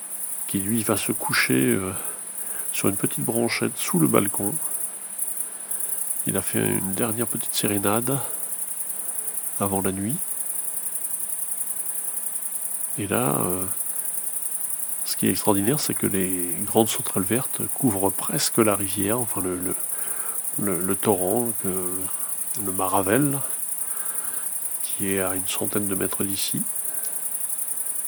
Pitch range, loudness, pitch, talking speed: 95-110 Hz, -23 LUFS, 100 Hz, 120 wpm